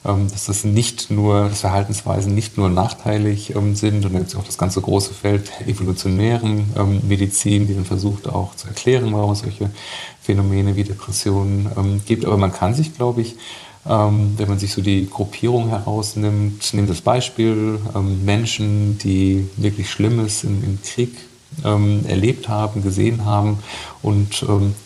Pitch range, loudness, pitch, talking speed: 100-110 Hz, -19 LUFS, 105 Hz, 140 wpm